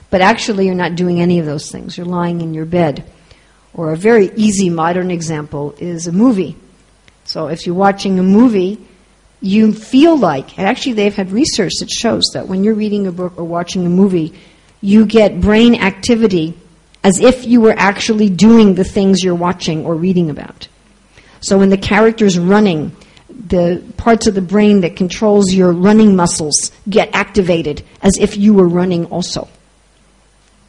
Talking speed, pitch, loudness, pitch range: 175 wpm, 190 Hz, -12 LUFS, 175-210 Hz